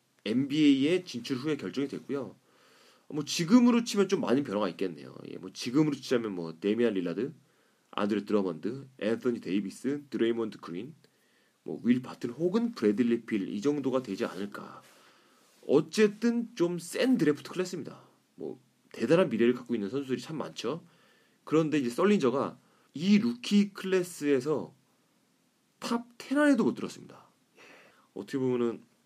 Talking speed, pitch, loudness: 320 characters per minute, 145 Hz, -29 LUFS